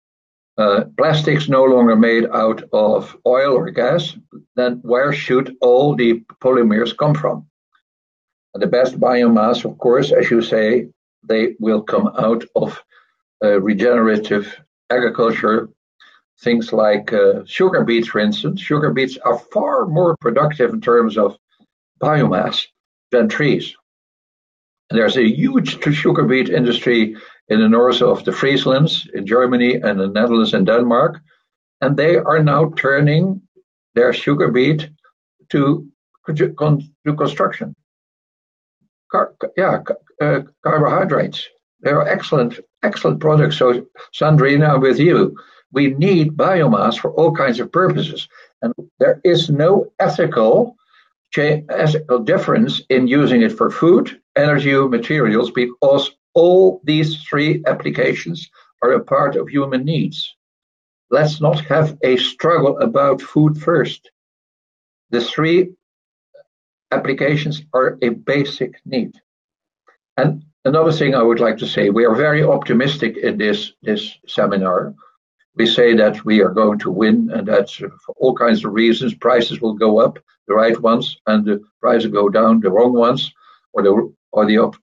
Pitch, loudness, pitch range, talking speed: 135 Hz, -16 LUFS, 115-155 Hz, 140 wpm